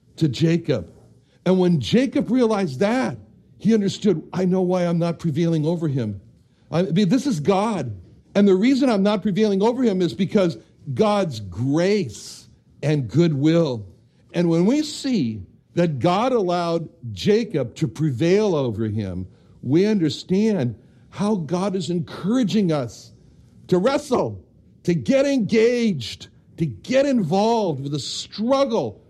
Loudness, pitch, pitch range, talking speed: -21 LUFS, 175 Hz, 135-210 Hz, 135 wpm